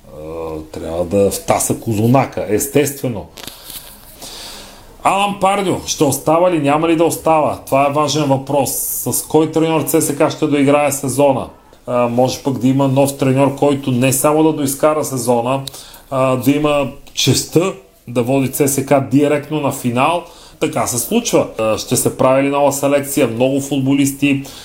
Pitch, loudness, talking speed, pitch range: 140 Hz, -15 LUFS, 140 wpm, 130-150 Hz